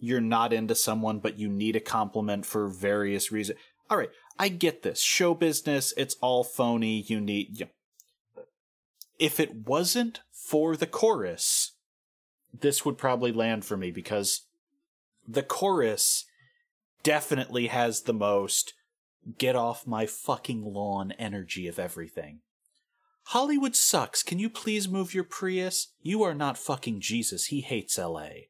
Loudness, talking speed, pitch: -28 LUFS, 145 wpm, 130 Hz